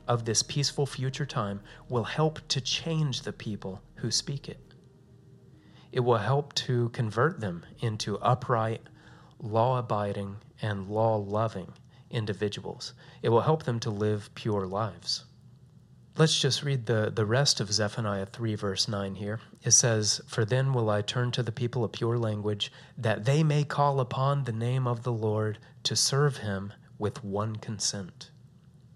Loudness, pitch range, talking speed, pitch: -29 LUFS, 105-135 Hz, 160 wpm, 120 Hz